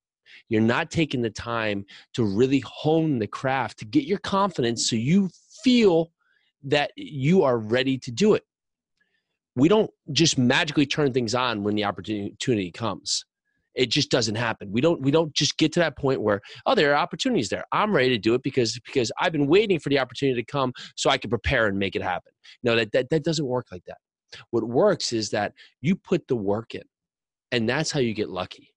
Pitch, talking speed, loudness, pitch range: 135 Hz, 210 wpm, -24 LUFS, 115-160 Hz